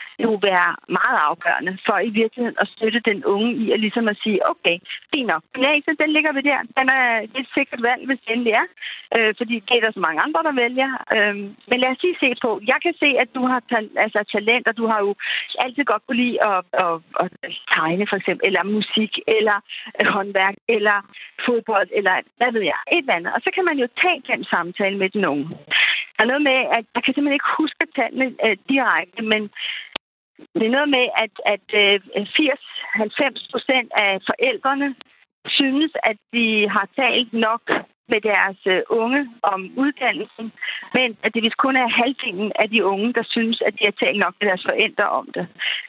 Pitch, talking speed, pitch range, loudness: 230 Hz, 195 wpm, 210-260 Hz, -19 LUFS